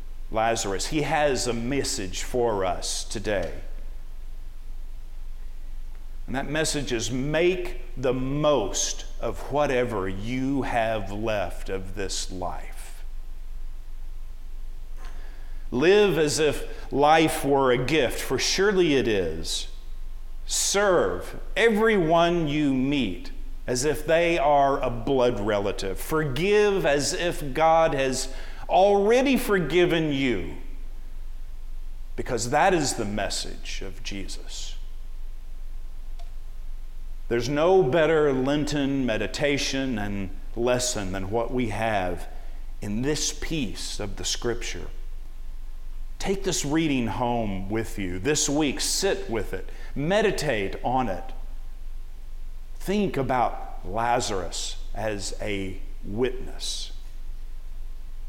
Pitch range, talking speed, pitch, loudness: 100-150 Hz, 100 wpm, 130 Hz, -25 LUFS